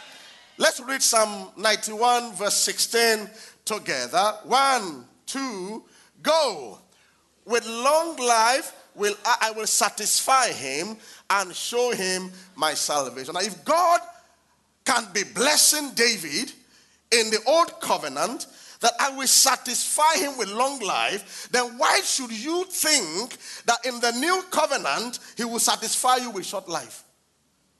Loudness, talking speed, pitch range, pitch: -22 LUFS, 130 wpm, 215-275 Hz, 240 Hz